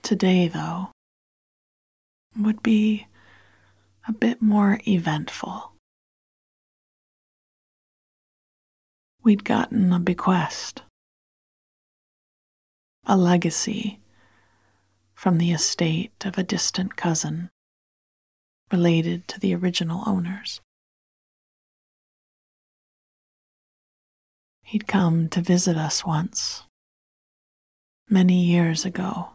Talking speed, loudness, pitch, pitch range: 70 wpm, -23 LUFS, 180 Hz, 165-205 Hz